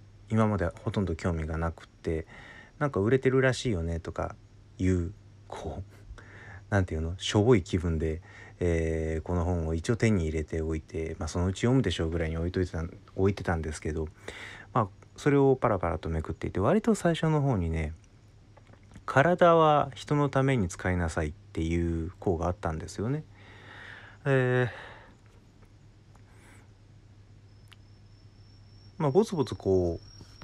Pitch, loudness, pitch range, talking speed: 100 Hz, -29 LUFS, 85-110 Hz, 300 characters per minute